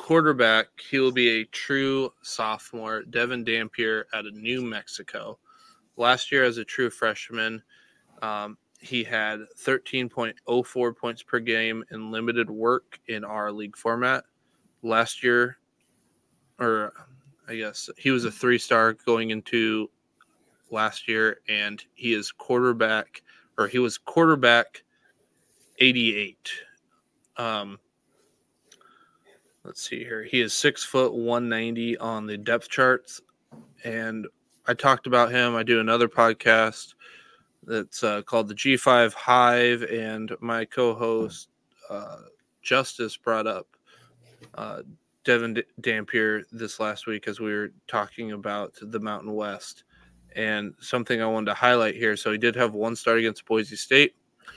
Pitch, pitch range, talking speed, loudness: 115 Hz, 110-120 Hz, 135 wpm, -24 LUFS